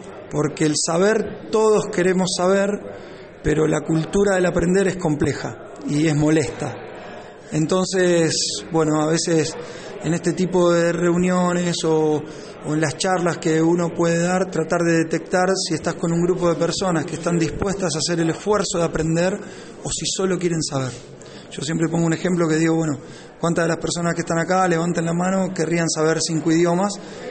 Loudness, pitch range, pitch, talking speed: -20 LUFS, 160-185 Hz, 170 Hz, 175 wpm